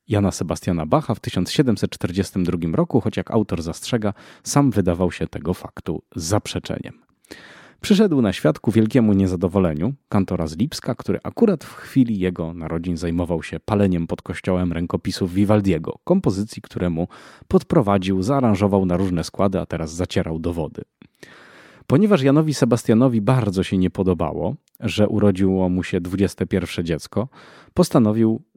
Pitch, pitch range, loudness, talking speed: 95 Hz, 90-110 Hz, -21 LUFS, 130 wpm